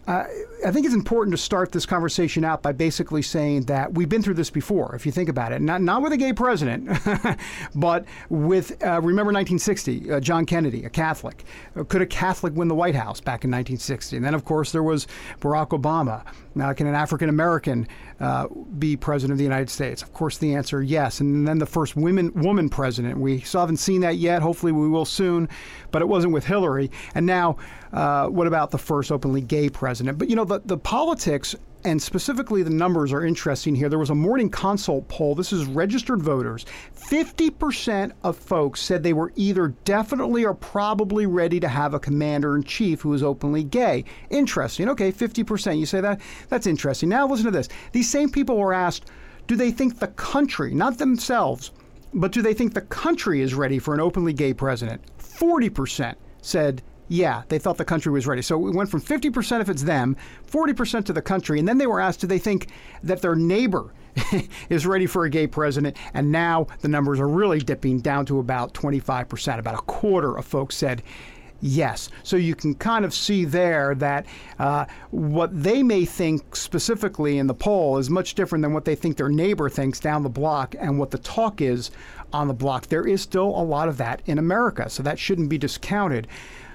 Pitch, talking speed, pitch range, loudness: 165 Hz, 205 wpm, 145-195 Hz, -23 LUFS